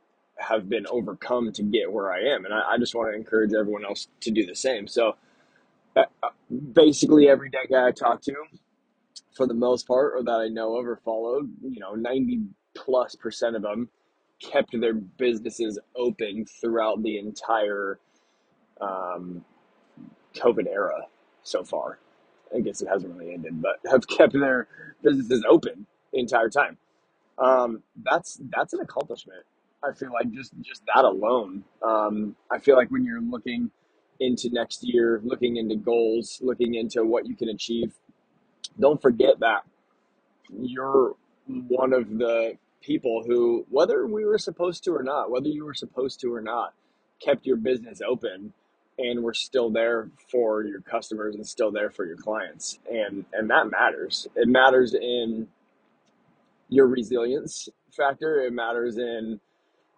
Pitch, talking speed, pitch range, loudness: 120 Hz, 160 wpm, 110-140 Hz, -25 LUFS